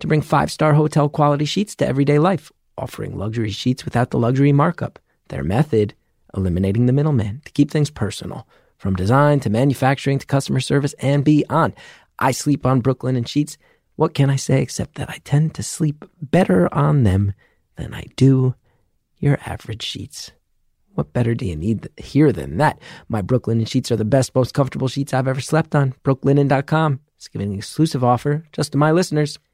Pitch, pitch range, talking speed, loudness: 140 Hz, 120-150 Hz, 185 wpm, -19 LUFS